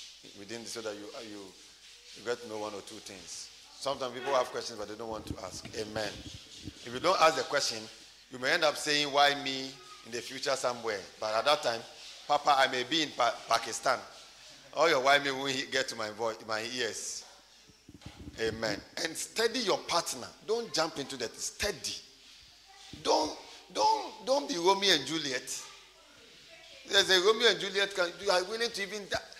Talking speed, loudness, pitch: 190 wpm, -30 LUFS, 140 Hz